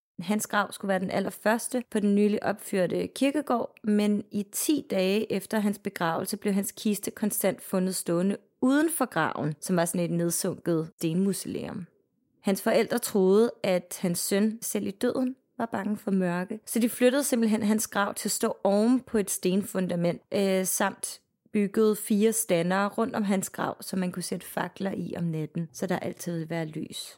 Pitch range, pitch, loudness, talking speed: 185-220 Hz, 205 Hz, -28 LUFS, 180 wpm